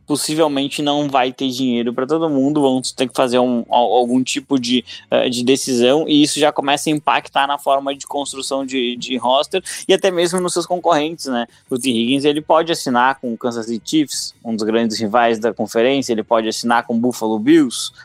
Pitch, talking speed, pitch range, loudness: 135 Hz, 205 wpm, 120-150 Hz, -17 LUFS